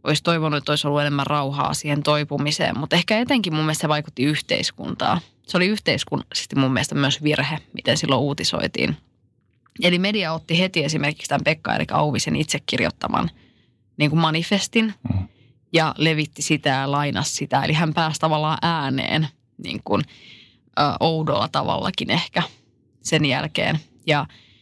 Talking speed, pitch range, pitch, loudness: 150 wpm, 140-160 Hz, 150 Hz, -21 LUFS